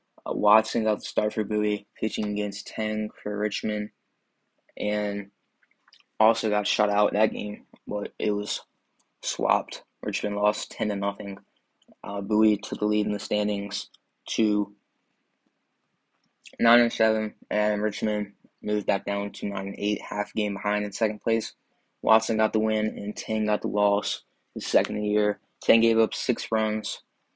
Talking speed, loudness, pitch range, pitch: 160 wpm, -26 LUFS, 105-110 Hz, 105 Hz